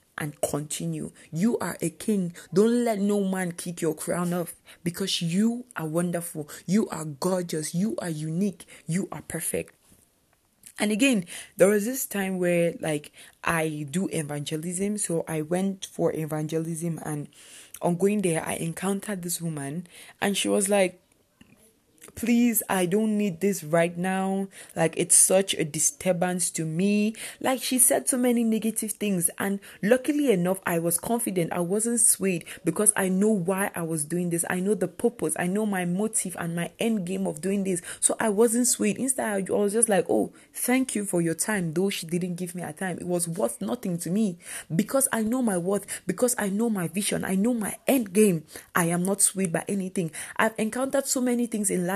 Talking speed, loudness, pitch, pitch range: 190 wpm, -26 LUFS, 190 Hz, 170-215 Hz